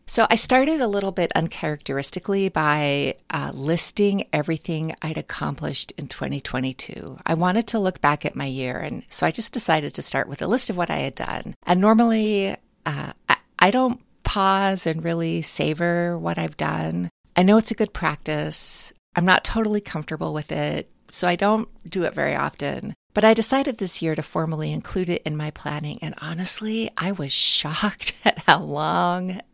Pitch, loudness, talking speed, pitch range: 175 Hz, -22 LUFS, 180 wpm, 150-205 Hz